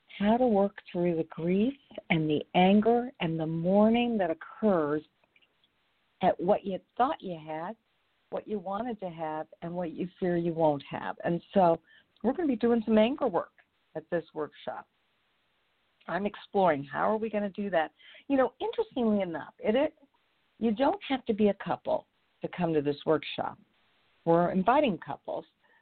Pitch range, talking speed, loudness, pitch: 165-230 Hz, 175 wpm, -29 LUFS, 195 Hz